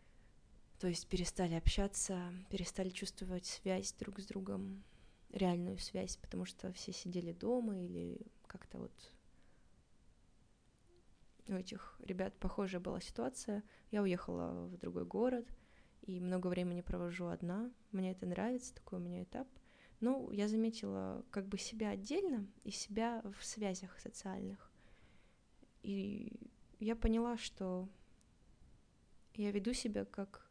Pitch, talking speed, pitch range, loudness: 190 Hz, 125 wpm, 175-215 Hz, -42 LUFS